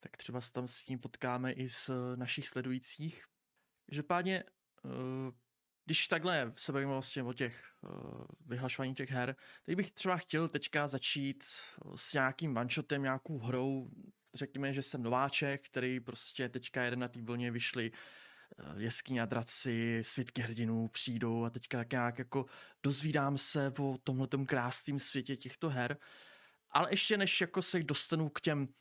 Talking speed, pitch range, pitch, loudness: 150 wpm, 125-145 Hz, 135 Hz, -37 LUFS